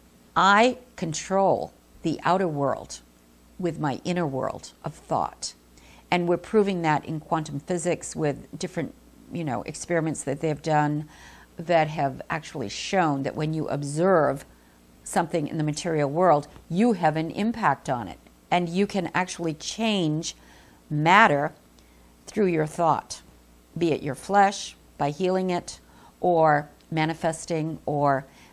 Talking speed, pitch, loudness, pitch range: 135 wpm, 155 Hz, -25 LUFS, 125-175 Hz